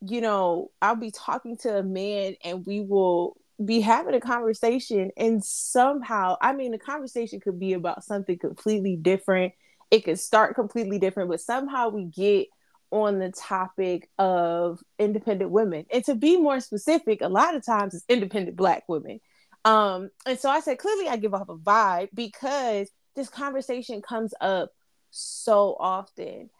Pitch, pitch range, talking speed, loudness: 215 Hz, 190-245 Hz, 165 wpm, -25 LUFS